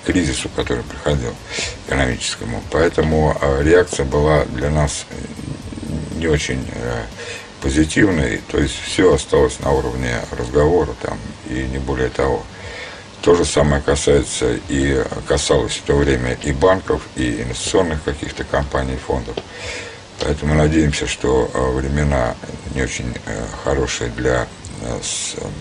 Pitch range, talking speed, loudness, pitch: 70-80 Hz, 130 wpm, -19 LUFS, 75 Hz